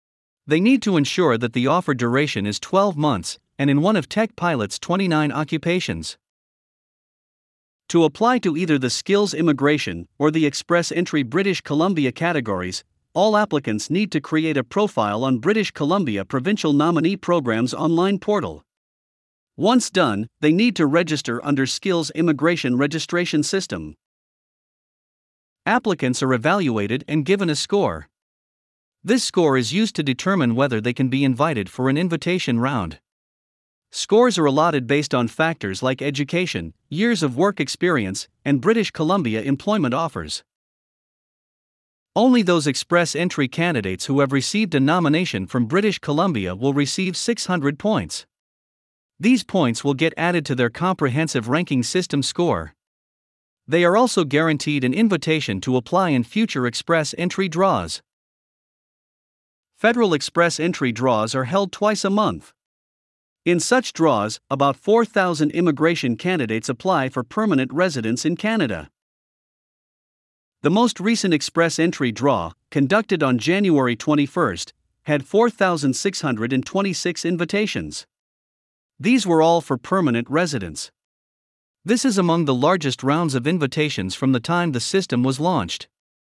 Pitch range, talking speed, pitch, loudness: 130-180 Hz, 135 wpm, 155 Hz, -20 LUFS